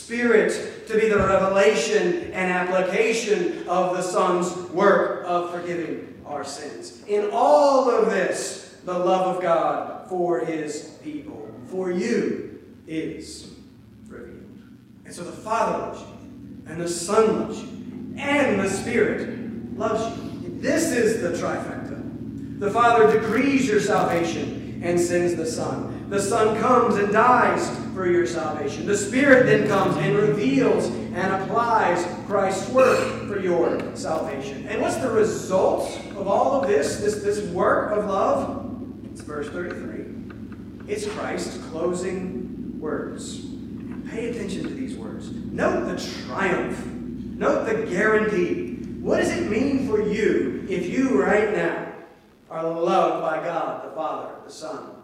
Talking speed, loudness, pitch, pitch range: 140 wpm, -23 LUFS, 205 Hz, 180-235 Hz